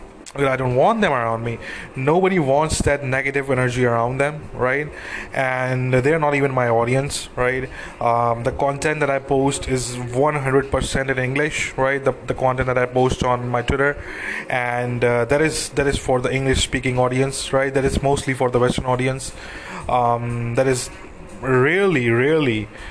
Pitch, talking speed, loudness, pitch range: 130 Hz, 170 wpm, -20 LUFS, 125-140 Hz